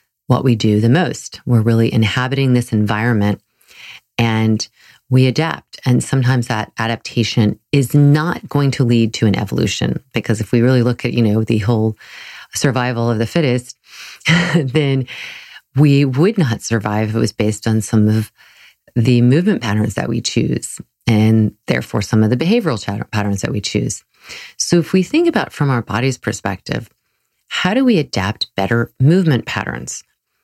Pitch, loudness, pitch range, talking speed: 120 Hz, -16 LUFS, 110-135 Hz, 165 wpm